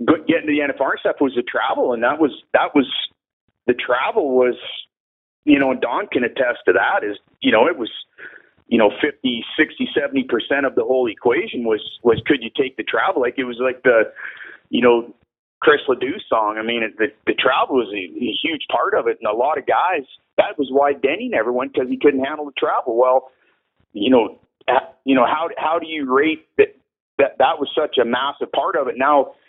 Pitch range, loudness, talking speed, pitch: 125-165 Hz, -19 LUFS, 220 wpm, 140 Hz